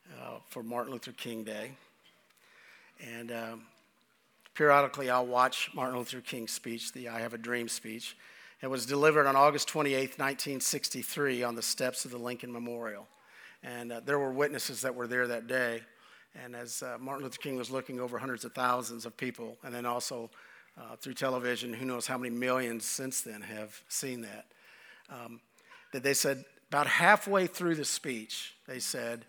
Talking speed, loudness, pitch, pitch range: 175 wpm, -32 LUFS, 125 Hz, 120-135 Hz